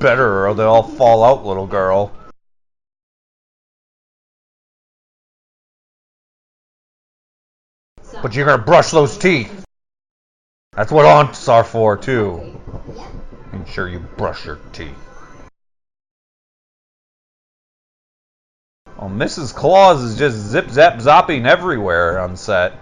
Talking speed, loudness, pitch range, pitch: 95 wpm, -14 LUFS, 95-115 Hz, 105 Hz